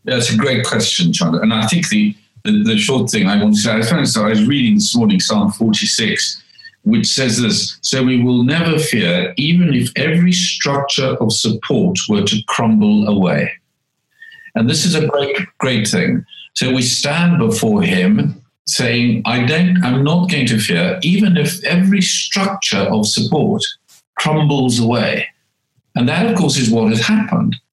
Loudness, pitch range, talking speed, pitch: -14 LUFS, 120-205 Hz, 170 wpm, 155 Hz